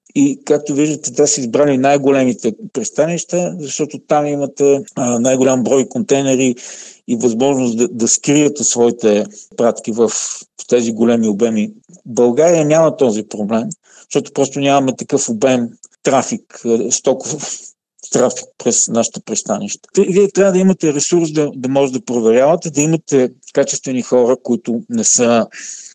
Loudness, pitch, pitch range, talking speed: -15 LUFS, 140 Hz, 120-155 Hz, 135 wpm